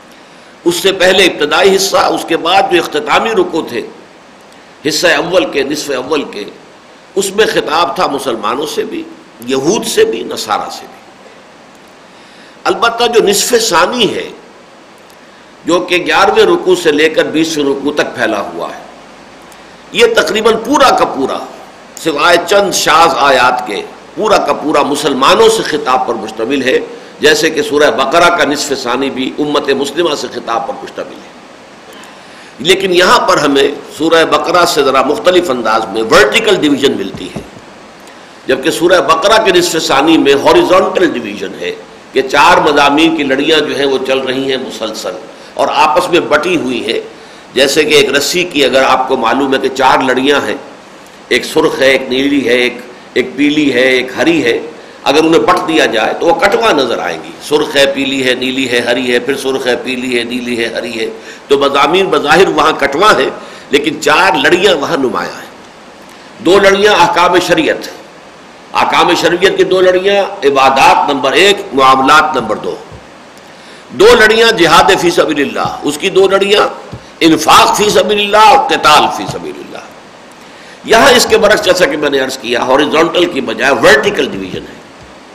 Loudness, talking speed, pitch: -10 LUFS, 170 wpm, 170 Hz